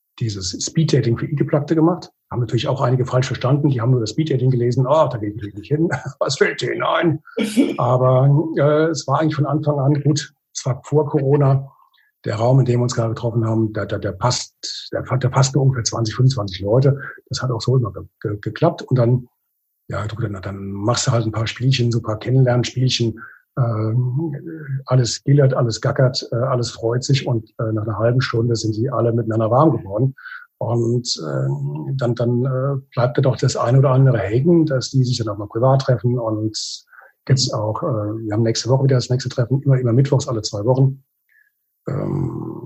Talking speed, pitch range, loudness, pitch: 205 wpm, 115-140 Hz, -19 LUFS, 125 Hz